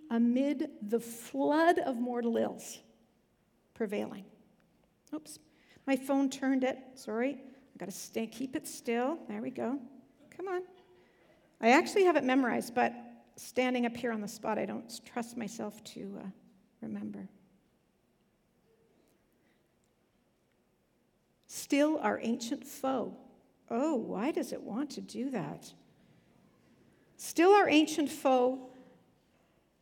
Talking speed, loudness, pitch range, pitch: 120 wpm, -32 LUFS, 225-280 Hz, 255 Hz